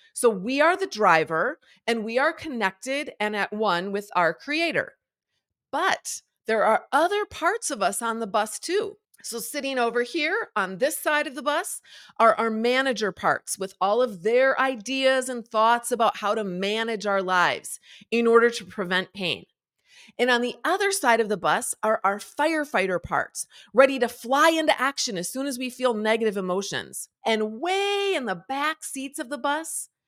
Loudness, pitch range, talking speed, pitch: -24 LUFS, 210-290 Hz, 180 wpm, 235 Hz